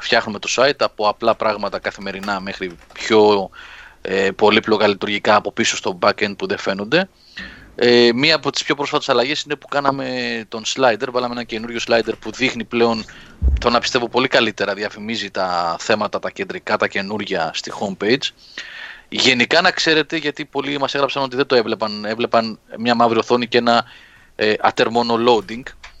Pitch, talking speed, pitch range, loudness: 115 Hz, 165 wpm, 105-135 Hz, -18 LUFS